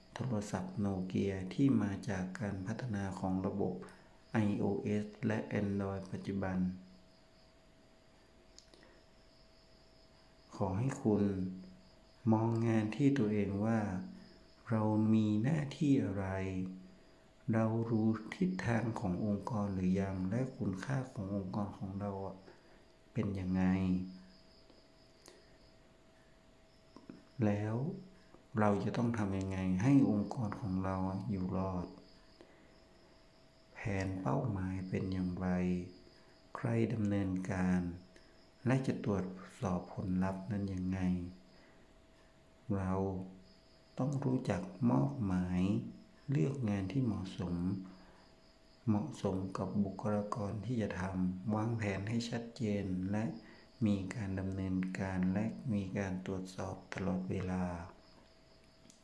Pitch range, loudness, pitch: 95-110 Hz, -37 LUFS, 100 Hz